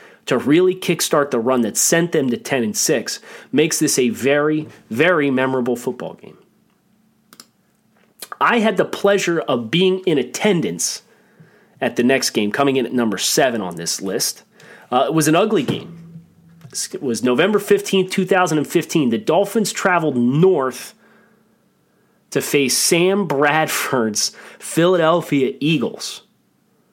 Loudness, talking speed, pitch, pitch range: -18 LUFS, 145 wpm, 165 Hz, 135-200 Hz